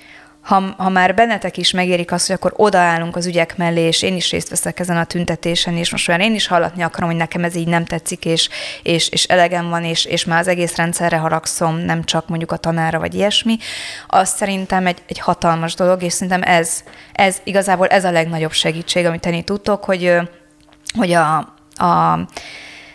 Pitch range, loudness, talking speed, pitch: 165-185 Hz, -16 LUFS, 195 wpm, 175 Hz